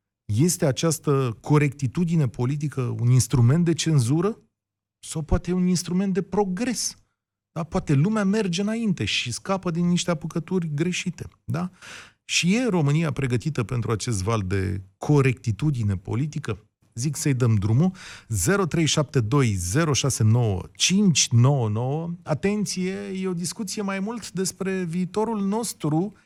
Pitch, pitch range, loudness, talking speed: 155 Hz, 120-180 Hz, -24 LUFS, 115 wpm